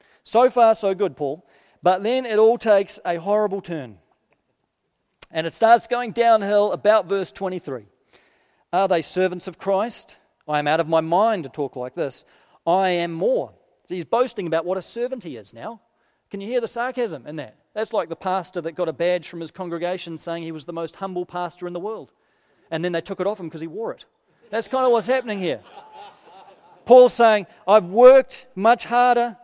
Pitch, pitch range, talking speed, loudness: 195 Hz, 170-230 Hz, 205 wpm, -21 LUFS